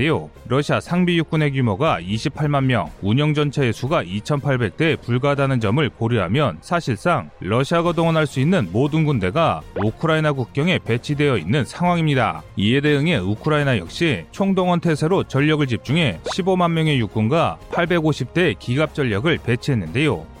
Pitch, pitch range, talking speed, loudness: 145 Hz, 115-160 Hz, 325 characters per minute, -20 LUFS